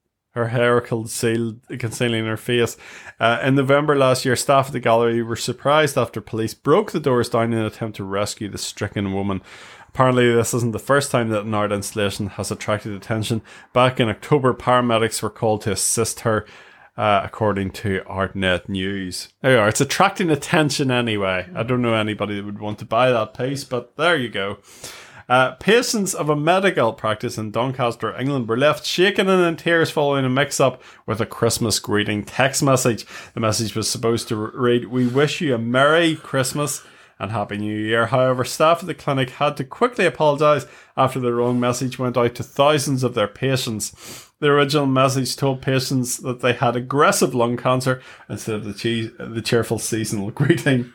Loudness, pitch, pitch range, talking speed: -20 LUFS, 120 Hz, 110-135 Hz, 185 wpm